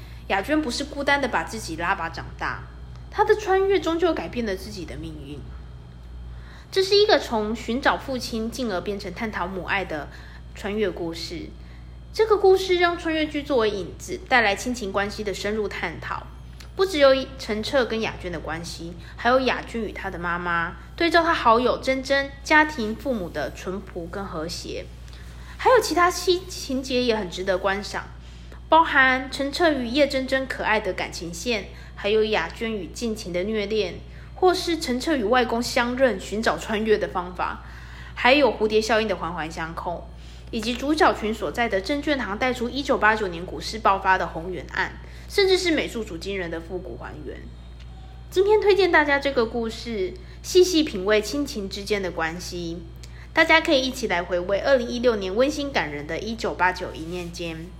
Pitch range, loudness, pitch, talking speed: 175-275 Hz, -23 LUFS, 215 Hz, 270 characters per minute